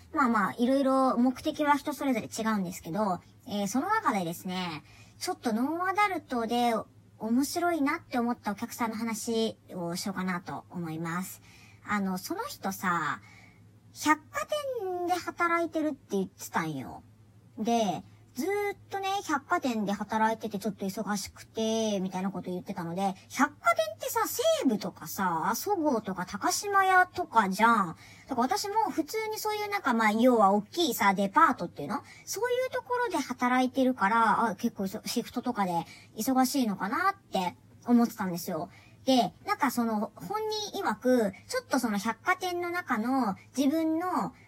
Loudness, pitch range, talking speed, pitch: -29 LUFS, 200-320 Hz, 330 characters per minute, 235 Hz